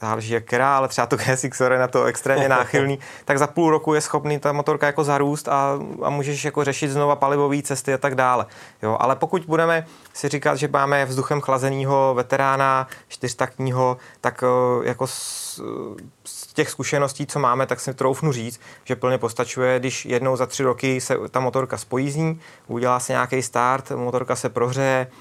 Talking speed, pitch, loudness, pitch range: 180 wpm, 135 Hz, -21 LUFS, 125-145 Hz